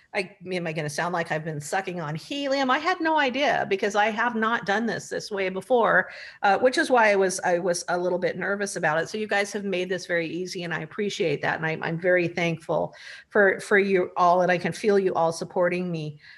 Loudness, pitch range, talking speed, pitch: -24 LUFS, 175-210 Hz, 250 wpm, 185 Hz